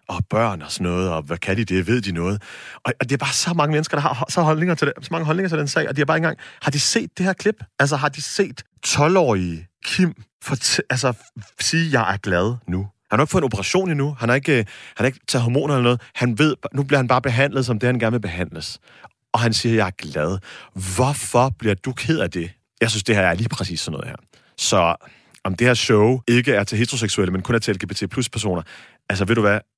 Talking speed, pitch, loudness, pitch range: 265 wpm, 120 Hz, -20 LUFS, 100-145 Hz